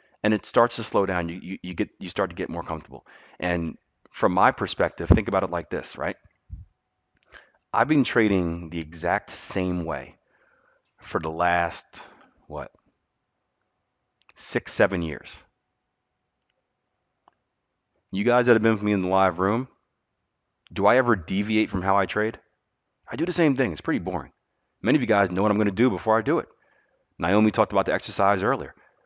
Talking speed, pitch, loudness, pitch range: 180 wpm, 100 Hz, -24 LUFS, 90-110 Hz